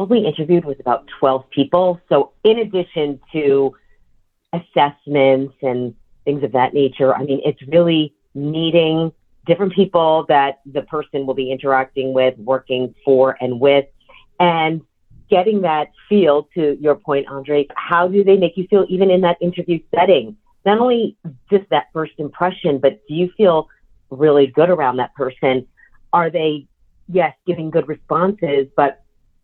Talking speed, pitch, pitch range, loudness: 155 wpm, 150 Hz, 135-175 Hz, -17 LUFS